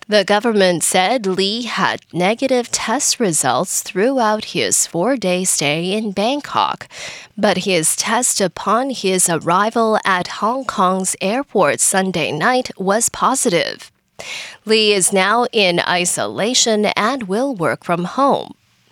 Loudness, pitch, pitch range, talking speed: -16 LUFS, 205 Hz, 185-230 Hz, 125 wpm